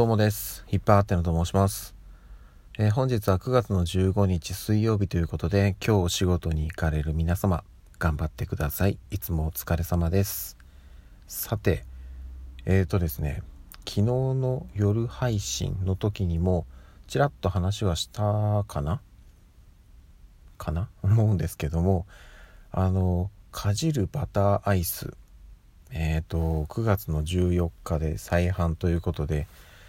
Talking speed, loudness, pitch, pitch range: 260 characters per minute, -27 LUFS, 90 Hz, 80-100 Hz